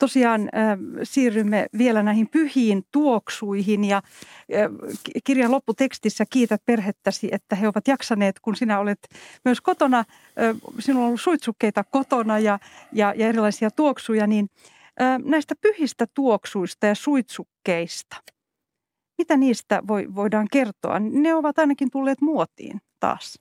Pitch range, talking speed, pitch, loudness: 210-270 Hz, 130 wpm, 230 Hz, -22 LUFS